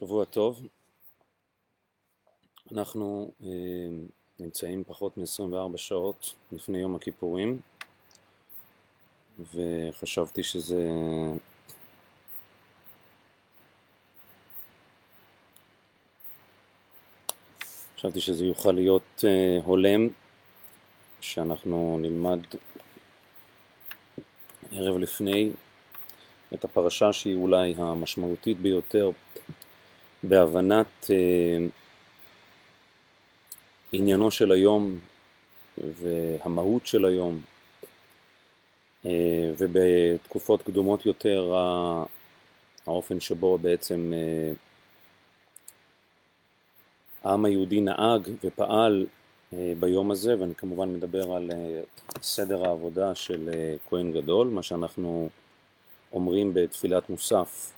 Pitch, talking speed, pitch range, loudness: 90 Hz, 70 wpm, 85-100 Hz, -27 LUFS